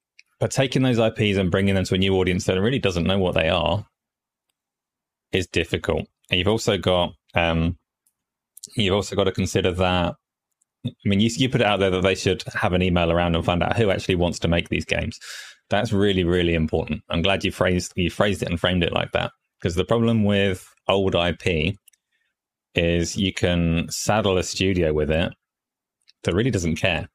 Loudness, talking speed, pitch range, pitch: -22 LUFS, 200 wpm, 85-100 Hz, 95 Hz